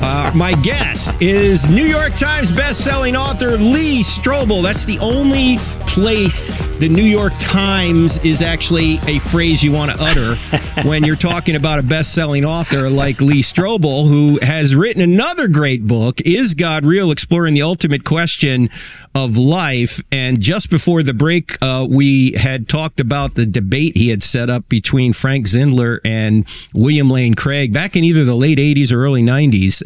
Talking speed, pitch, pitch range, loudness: 170 wpm, 145 Hz, 130-170 Hz, -13 LUFS